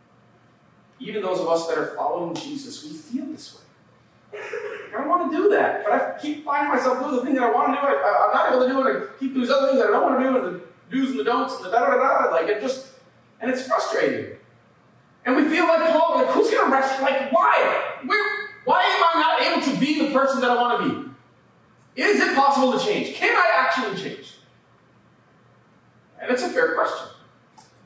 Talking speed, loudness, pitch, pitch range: 225 wpm, -21 LUFS, 275 Hz, 255-330 Hz